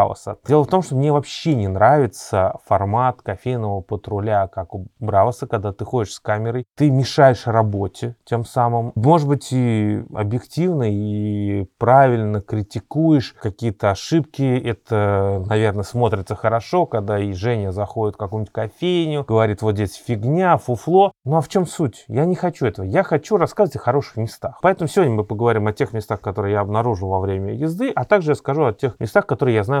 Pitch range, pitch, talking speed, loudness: 105-145 Hz, 115 Hz, 175 wpm, -19 LUFS